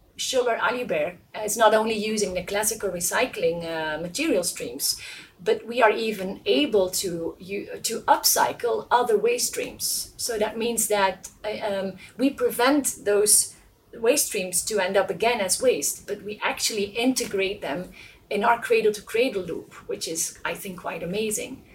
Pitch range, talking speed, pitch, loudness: 195-240 Hz, 155 wpm, 210 Hz, -24 LUFS